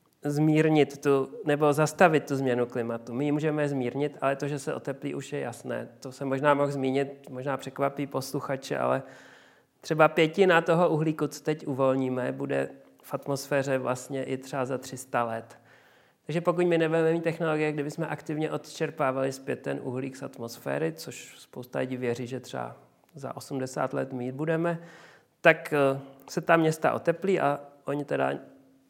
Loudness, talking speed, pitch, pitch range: -28 LUFS, 160 wpm, 140 Hz, 130-155 Hz